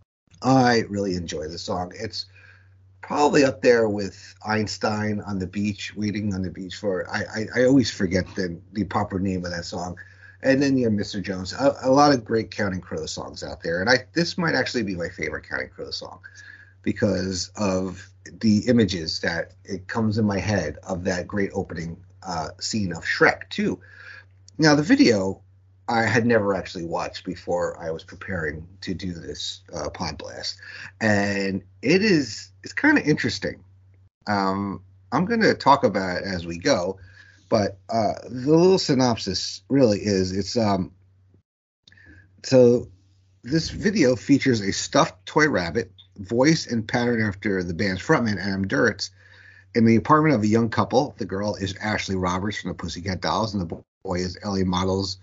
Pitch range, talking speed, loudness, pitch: 95-115 Hz, 170 wpm, -23 LUFS, 100 Hz